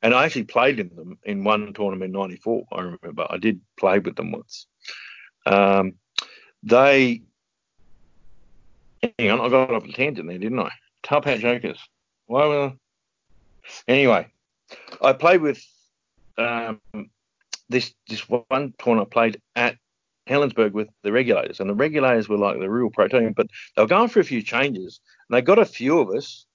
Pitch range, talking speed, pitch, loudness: 105-130 Hz, 170 wpm, 115 Hz, -21 LUFS